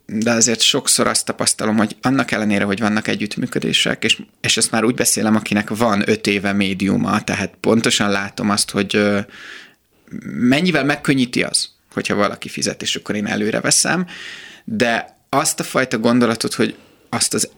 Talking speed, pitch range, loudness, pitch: 155 wpm, 100-125 Hz, -17 LUFS, 110 Hz